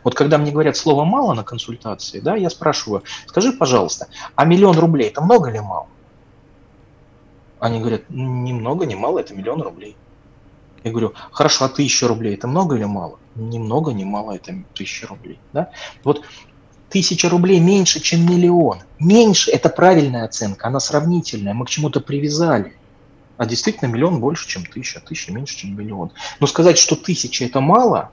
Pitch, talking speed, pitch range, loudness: 145 Hz, 170 wpm, 115-170 Hz, -17 LUFS